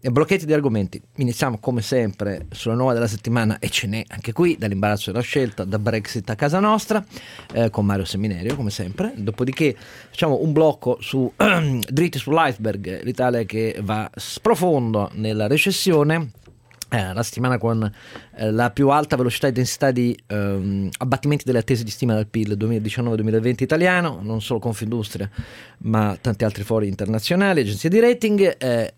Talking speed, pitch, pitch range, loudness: 165 wpm, 115 Hz, 110-135 Hz, -21 LUFS